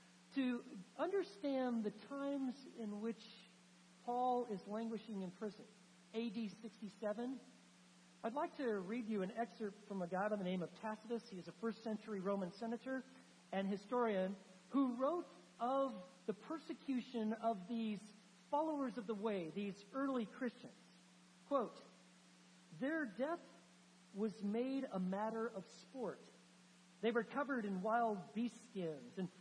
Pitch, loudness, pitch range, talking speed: 220 Hz, -44 LUFS, 190-245 Hz, 140 wpm